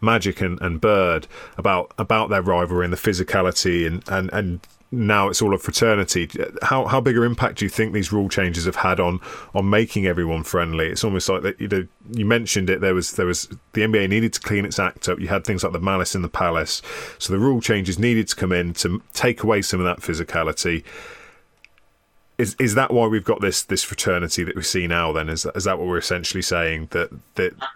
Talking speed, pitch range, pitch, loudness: 225 wpm, 90-110 Hz, 95 Hz, -21 LUFS